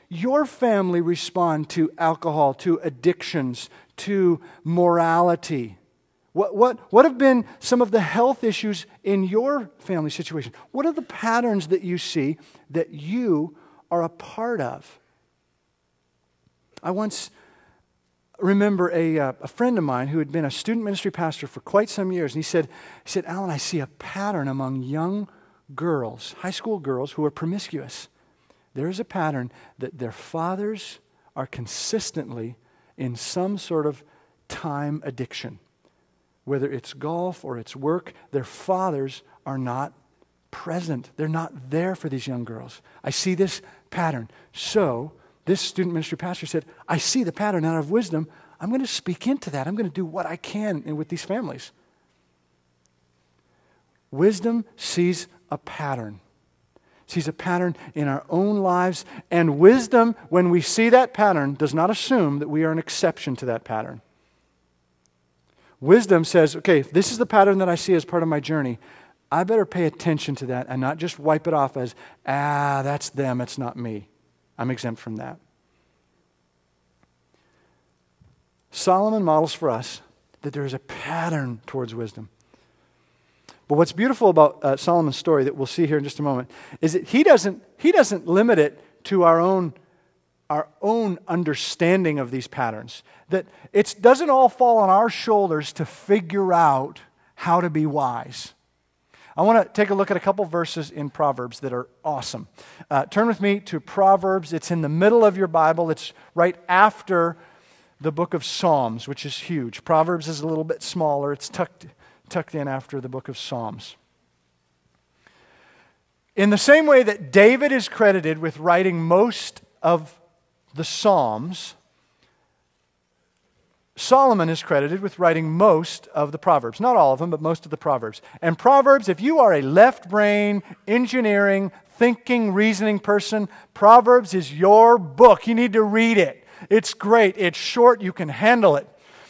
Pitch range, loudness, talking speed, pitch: 140-195 Hz, -21 LUFS, 165 wpm, 165 Hz